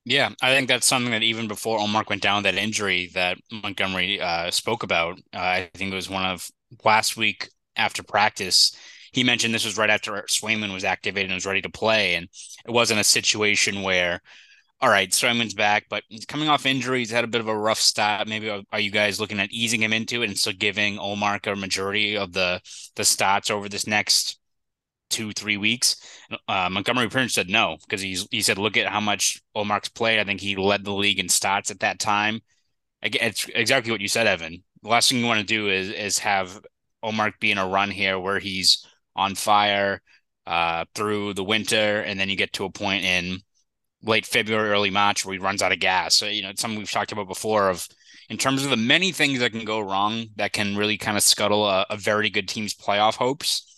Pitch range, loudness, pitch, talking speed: 100-110 Hz, -22 LUFS, 105 Hz, 220 wpm